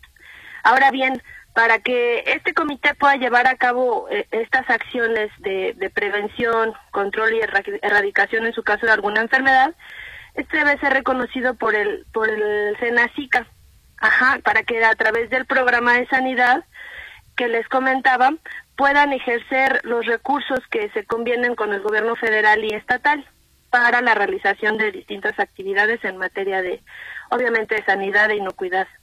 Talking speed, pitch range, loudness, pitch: 145 wpm, 215-270 Hz, -18 LUFS, 240 Hz